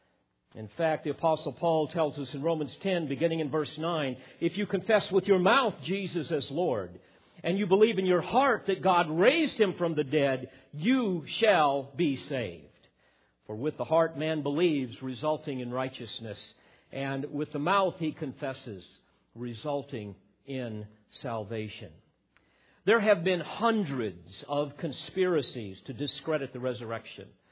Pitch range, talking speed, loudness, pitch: 130-170 Hz, 150 wpm, -29 LUFS, 150 Hz